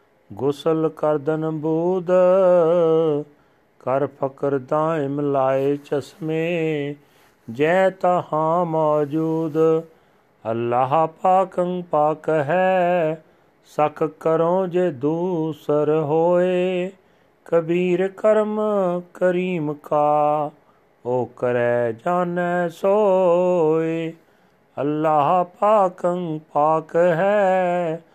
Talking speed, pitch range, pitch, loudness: 70 wpm, 150-180 Hz, 160 Hz, -20 LUFS